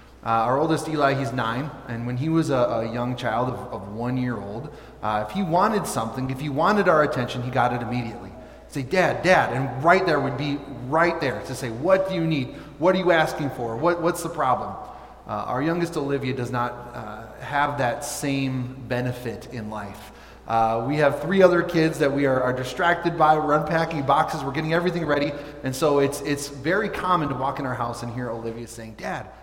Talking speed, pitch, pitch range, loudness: 220 wpm, 140 Hz, 120-155 Hz, -23 LUFS